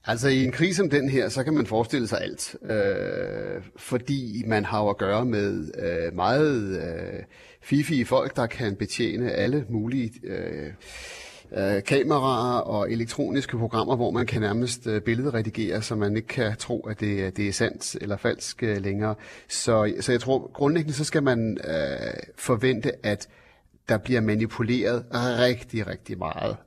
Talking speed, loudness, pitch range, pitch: 165 wpm, -26 LUFS, 110-135 Hz, 120 Hz